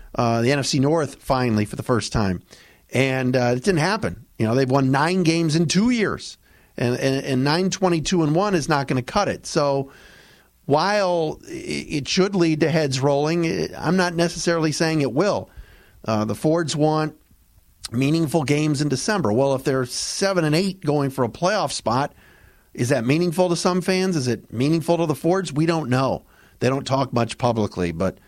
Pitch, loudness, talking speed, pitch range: 150 Hz, -21 LUFS, 190 wpm, 130-170 Hz